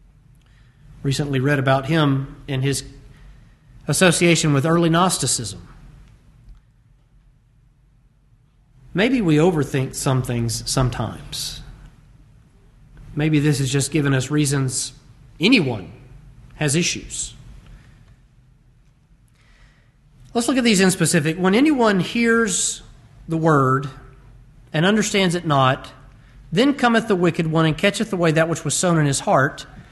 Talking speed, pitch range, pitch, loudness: 110 wpm, 130-160 Hz, 140 Hz, -19 LUFS